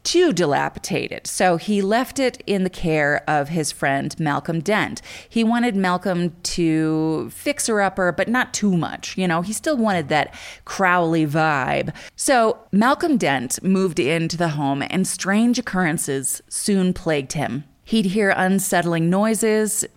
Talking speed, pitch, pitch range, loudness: 150 wpm, 185 Hz, 160-210 Hz, -20 LUFS